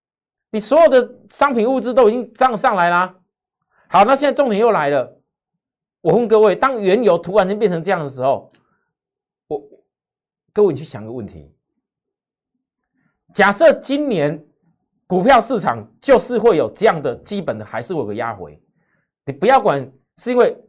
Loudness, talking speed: -16 LUFS, 240 characters per minute